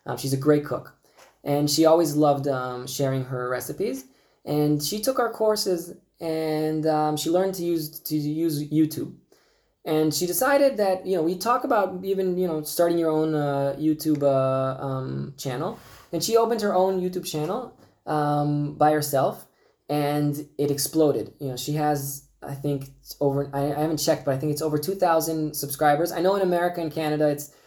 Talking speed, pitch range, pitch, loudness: 190 wpm, 145-170 Hz, 150 Hz, -24 LUFS